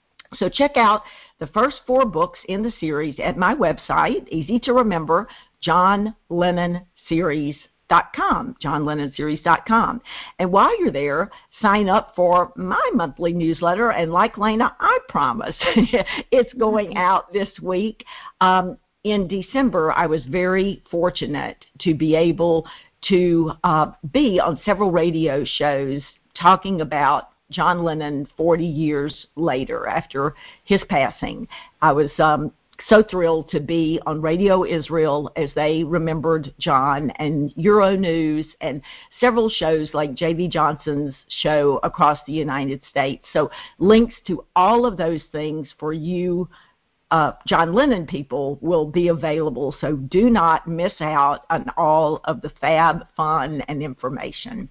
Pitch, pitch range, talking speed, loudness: 165 Hz, 155-195 Hz, 135 wpm, -20 LUFS